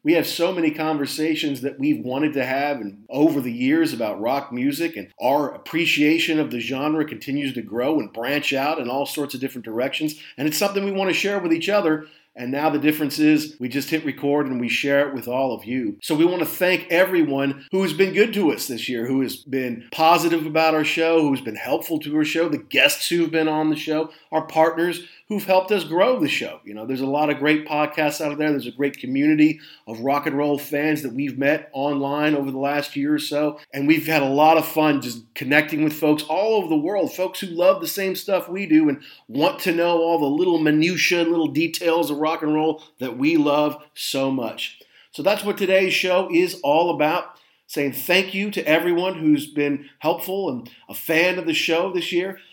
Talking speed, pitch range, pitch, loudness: 225 wpm, 145-175 Hz, 155 Hz, -21 LUFS